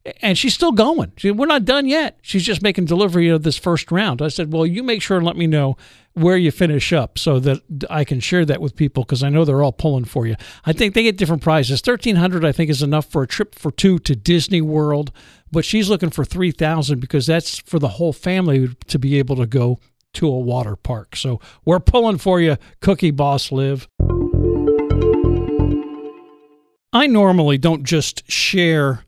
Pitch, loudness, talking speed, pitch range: 155 Hz, -17 LUFS, 205 wpm, 135-180 Hz